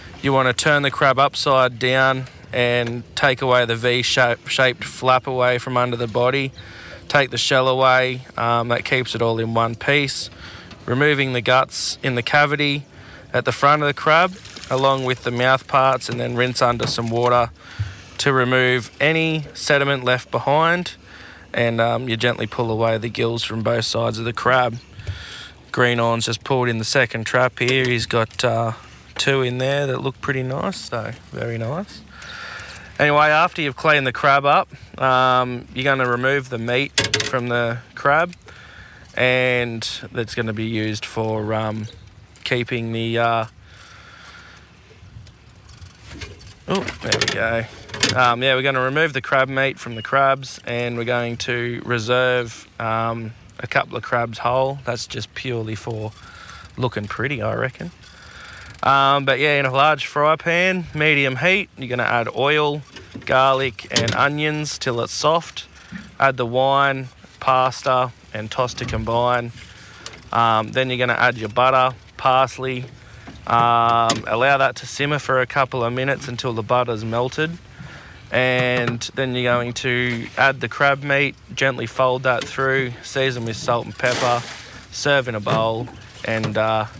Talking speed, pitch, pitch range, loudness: 160 wpm, 125 Hz, 115-135 Hz, -19 LUFS